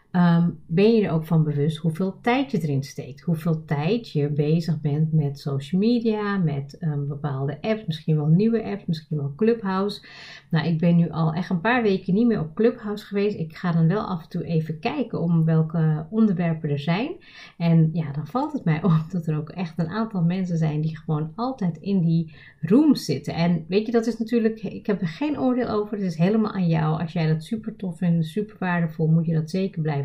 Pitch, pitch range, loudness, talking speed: 170 Hz, 160-210 Hz, -23 LUFS, 220 wpm